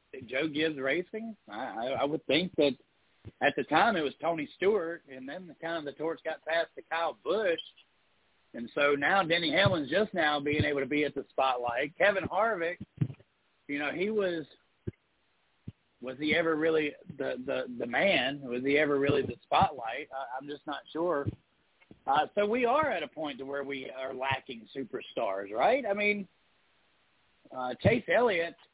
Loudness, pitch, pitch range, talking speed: -30 LUFS, 150 Hz, 135-175 Hz, 175 wpm